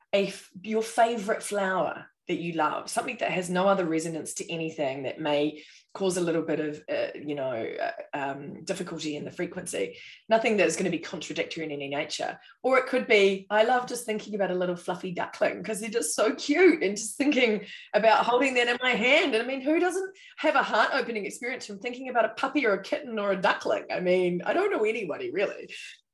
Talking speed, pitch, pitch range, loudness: 220 wpm, 215 Hz, 180-255 Hz, -27 LUFS